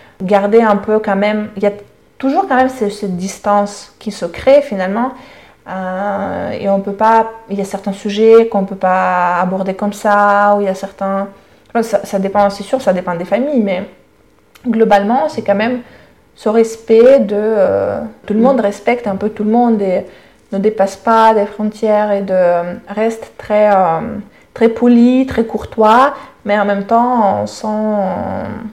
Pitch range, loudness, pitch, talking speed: 195-225 Hz, -14 LUFS, 210 Hz, 185 wpm